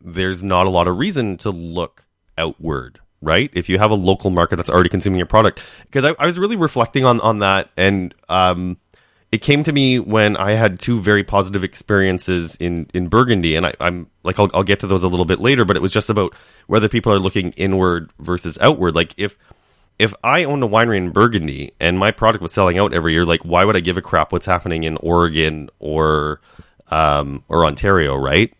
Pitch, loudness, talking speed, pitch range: 95 Hz, -17 LUFS, 220 wpm, 85-105 Hz